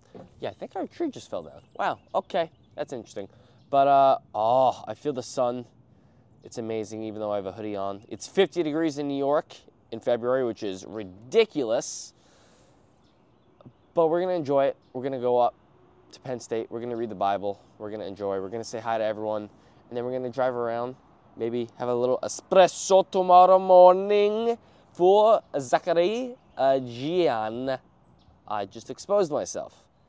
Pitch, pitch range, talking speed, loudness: 125 Hz, 110-165 Hz, 170 wpm, -25 LUFS